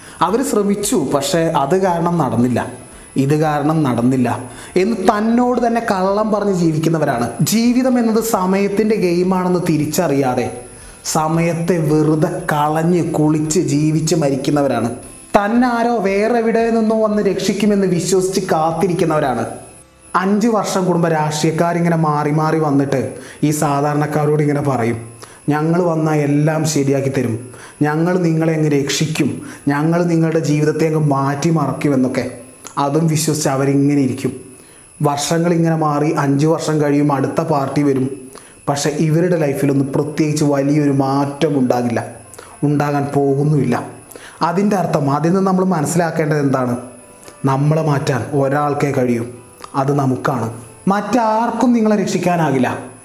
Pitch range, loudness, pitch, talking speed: 140-175 Hz, -16 LUFS, 155 Hz, 110 wpm